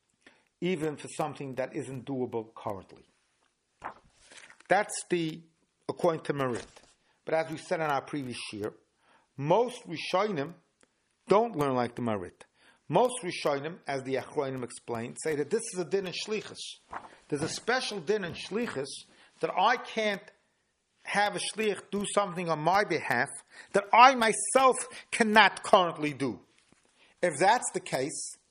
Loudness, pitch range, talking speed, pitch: -29 LUFS, 140-205 Hz, 145 wpm, 170 Hz